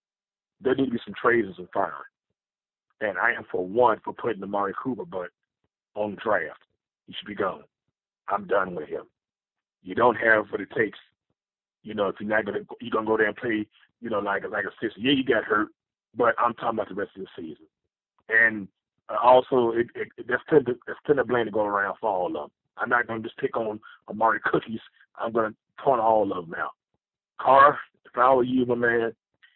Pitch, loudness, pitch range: 115 Hz, -25 LUFS, 105-120 Hz